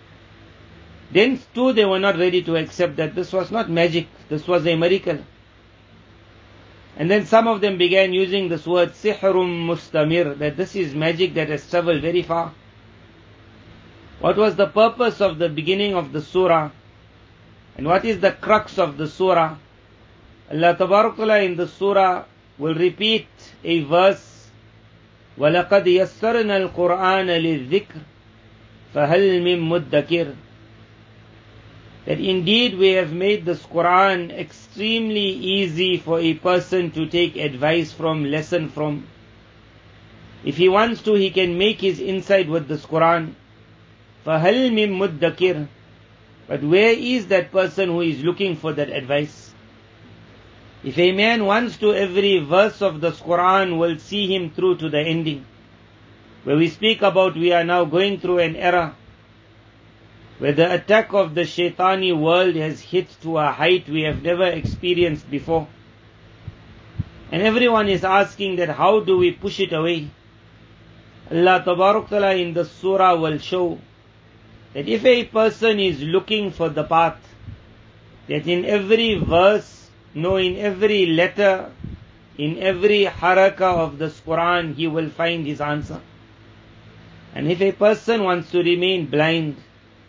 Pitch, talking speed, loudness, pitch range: 165 Hz, 140 wpm, -19 LUFS, 115-190 Hz